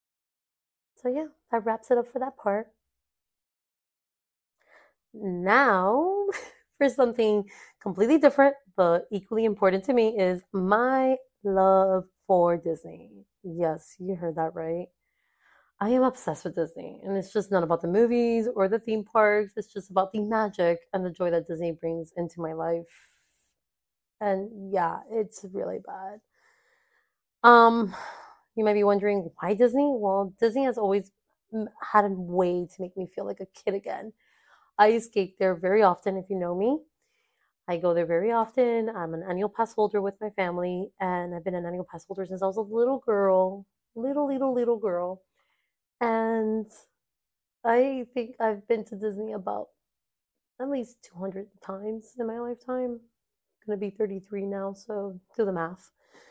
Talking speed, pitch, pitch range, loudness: 160 wpm, 205 Hz, 185-230 Hz, -26 LUFS